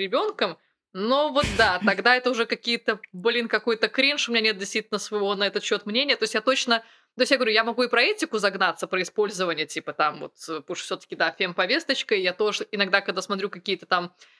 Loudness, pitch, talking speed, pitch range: -24 LUFS, 215 Hz, 215 wpm, 190-240 Hz